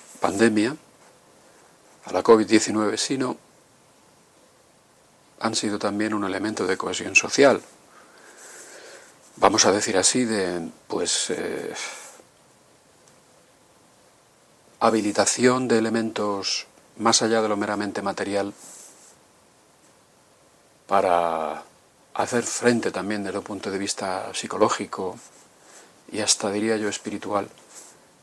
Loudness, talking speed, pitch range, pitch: -23 LUFS, 95 wpm, 100-115 Hz, 105 Hz